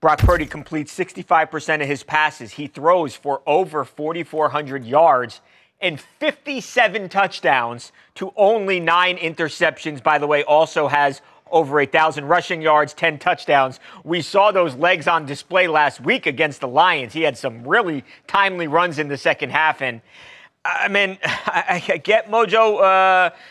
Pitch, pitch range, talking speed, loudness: 160 Hz, 150-185 Hz, 155 wpm, -18 LUFS